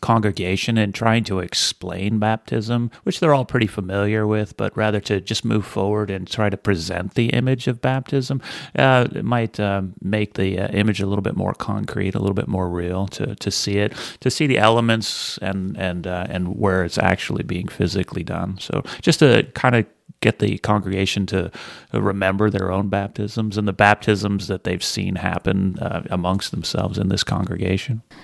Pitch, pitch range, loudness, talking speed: 100 Hz, 95-110 Hz, -21 LUFS, 185 wpm